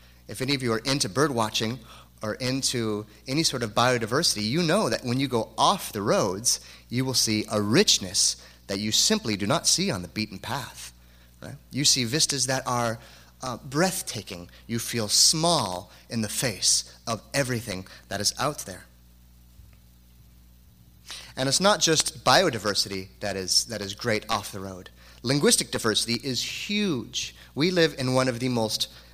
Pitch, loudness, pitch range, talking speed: 110 Hz, -24 LUFS, 90-130 Hz, 170 wpm